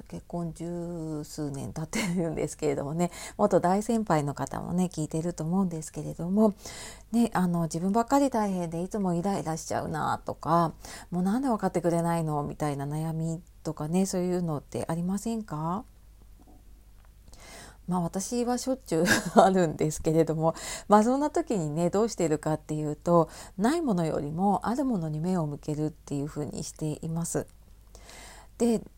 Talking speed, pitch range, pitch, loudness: 350 characters per minute, 150-195 Hz, 170 Hz, -28 LUFS